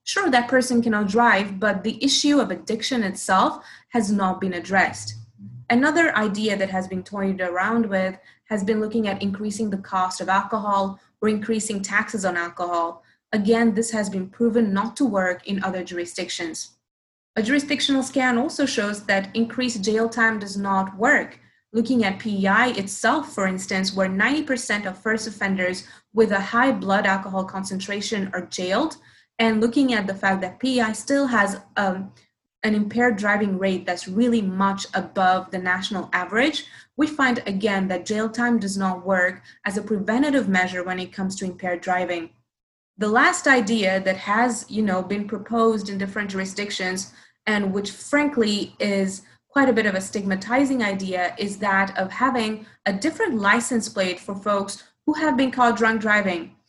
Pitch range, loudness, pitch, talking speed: 190-230 Hz, -22 LUFS, 205 Hz, 165 wpm